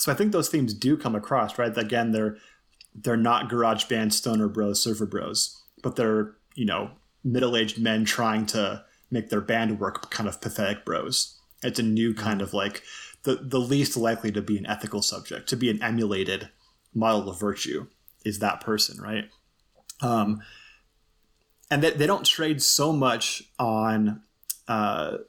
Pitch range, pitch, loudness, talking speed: 105-125 Hz, 110 Hz, -26 LUFS, 175 wpm